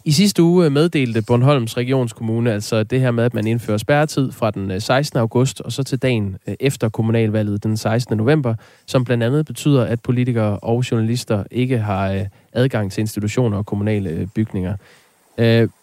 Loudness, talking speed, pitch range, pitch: -19 LUFS, 165 wpm, 110-130 Hz, 115 Hz